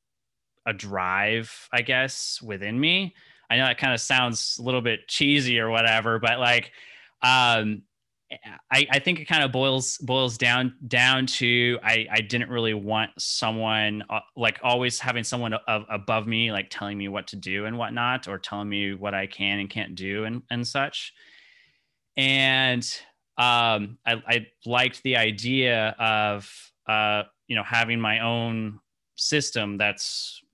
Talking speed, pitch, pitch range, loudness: 160 wpm, 115 Hz, 105-125 Hz, -23 LUFS